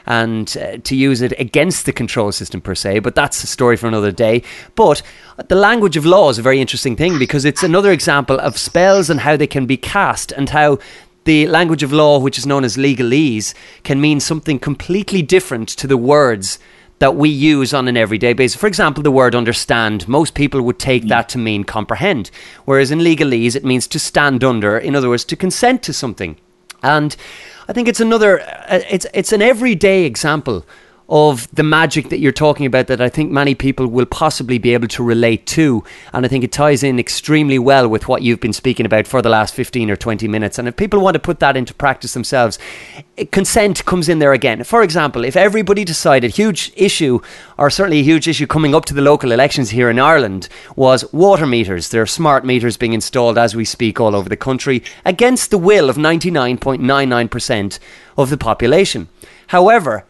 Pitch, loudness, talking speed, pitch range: 135 Hz, -14 LUFS, 205 wpm, 120-155 Hz